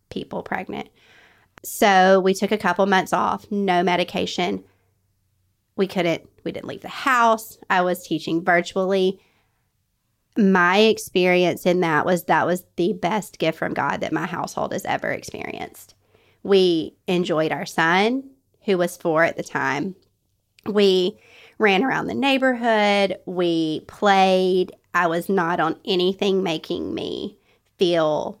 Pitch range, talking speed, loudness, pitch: 170-200 Hz, 135 wpm, -21 LUFS, 185 Hz